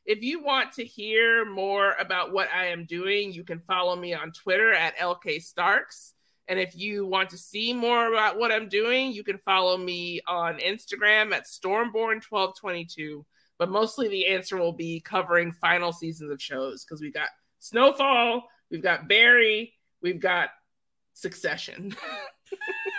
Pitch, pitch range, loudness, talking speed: 195 Hz, 175-230 Hz, -25 LUFS, 155 wpm